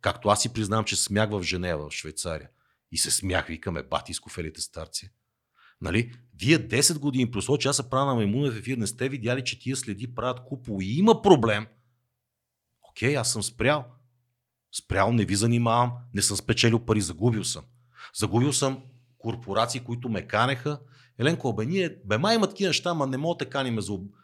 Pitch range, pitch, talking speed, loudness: 105-135 Hz, 120 Hz, 185 wpm, -26 LUFS